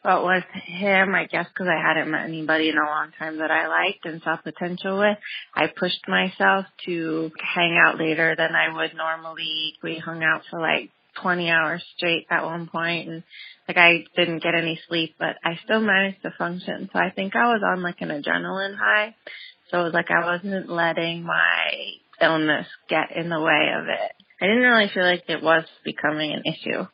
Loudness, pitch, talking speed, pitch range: -22 LUFS, 170 Hz, 205 wpm, 160-185 Hz